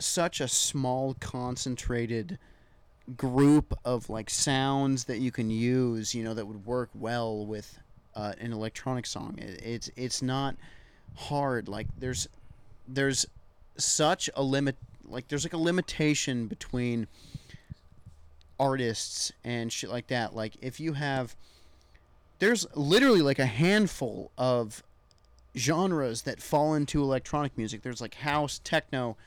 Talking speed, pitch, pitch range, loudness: 135 wpm, 125 Hz, 110-140 Hz, -29 LUFS